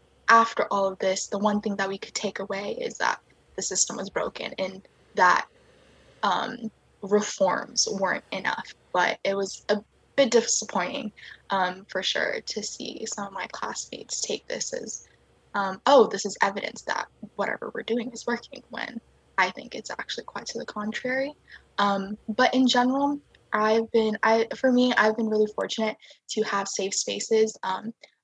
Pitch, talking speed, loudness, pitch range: 215 Hz, 170 wpm, -26 LUFS, 200-240 Hz